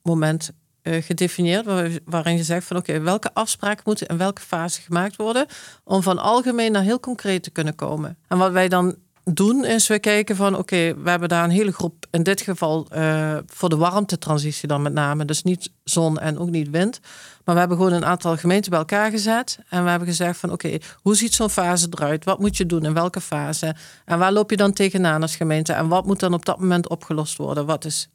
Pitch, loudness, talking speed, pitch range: 175 Hz, -21 LUFS, 230 wpm, 160-195 Hz